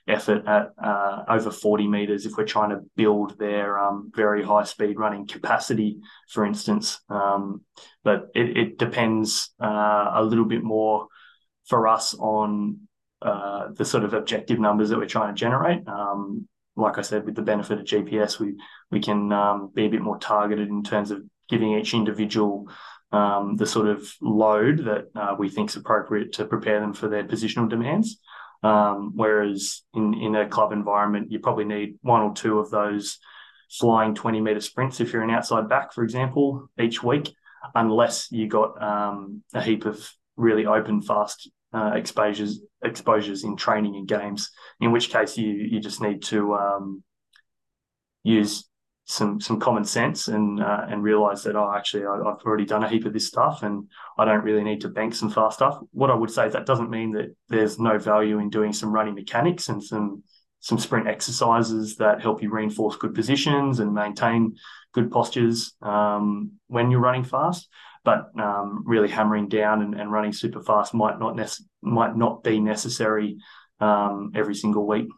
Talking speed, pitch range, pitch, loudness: 185 wpm, 105-110 Hz, 105 Hz, -24 LUFS